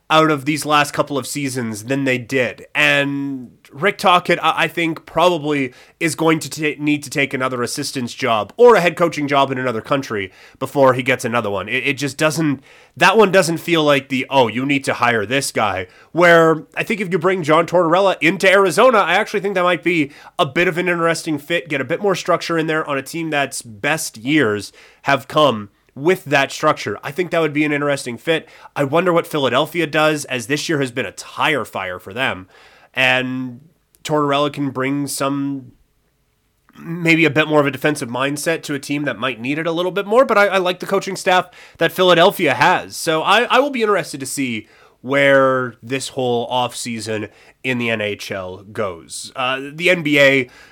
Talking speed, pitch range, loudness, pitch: 205 wpm, 130-170 Hz, -17 LUFS, 145 Hz